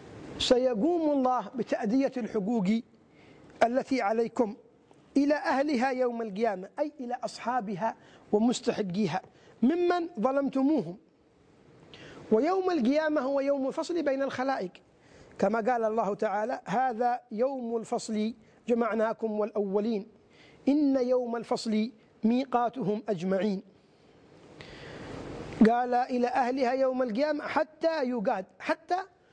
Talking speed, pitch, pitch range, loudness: 90 wpm, 245 Hz, 215-270 Hz, -29 LUFS